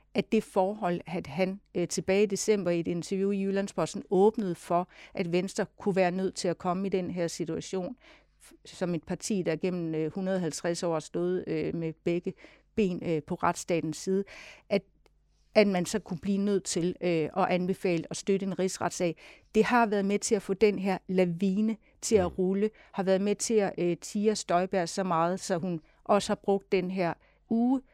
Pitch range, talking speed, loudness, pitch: 175-200 Hz, 195 wpm, -29 LUFS, 190 Hz